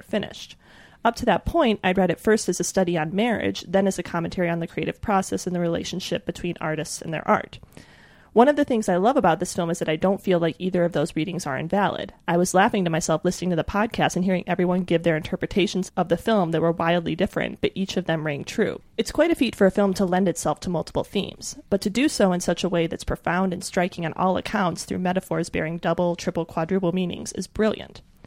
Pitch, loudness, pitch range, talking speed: 180 Hz, -23 LUFS, 170-195 Hz, 245 wpm